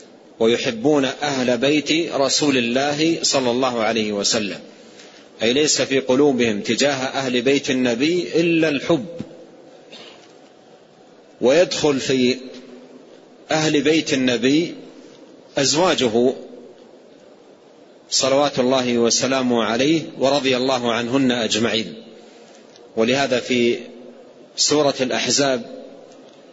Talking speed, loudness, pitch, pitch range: 85 wpm, -19 LUFS, 130 Hz, 125-145 Hz